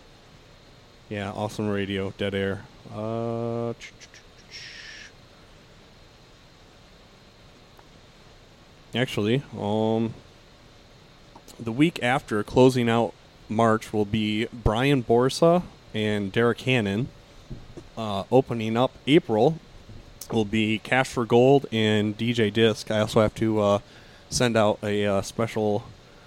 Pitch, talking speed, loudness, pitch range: 115 Hz, 100 wpm, -24 LUFS, 105-120 Hz